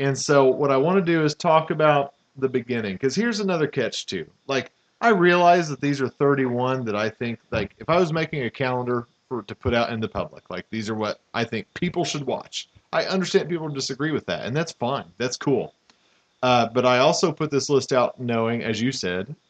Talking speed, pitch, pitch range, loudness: 225 wpm, 135 Hz, 120-160 Hz, -23 LUFS